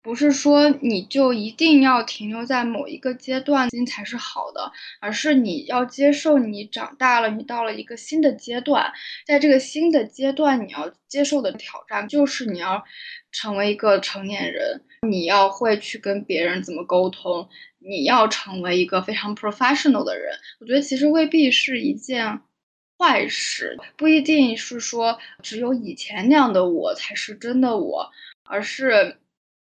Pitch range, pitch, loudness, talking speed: 210-285 Hz, 250 Hz, -21 LUFS, 265 characters per minute